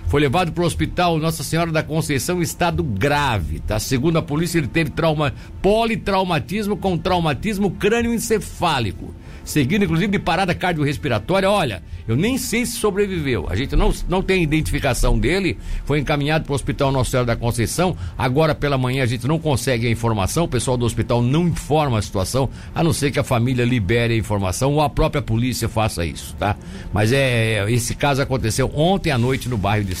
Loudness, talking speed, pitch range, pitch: -20 LUFS, 190 wpm, 115-170 Hz, 140 Hz